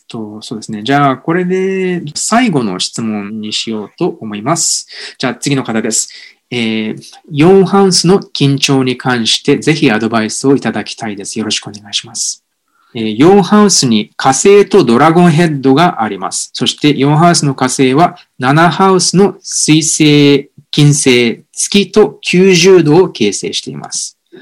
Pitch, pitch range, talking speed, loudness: 140 Hz, 115-180 Hz, 290 characters per minute, -10 LUFS